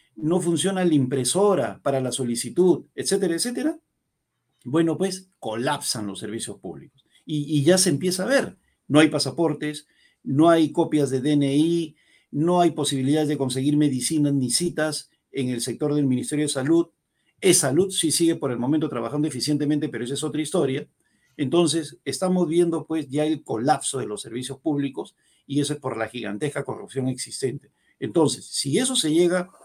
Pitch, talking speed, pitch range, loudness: 150 Hz, 170 wpm, 135-170 Hz, -23 LUFS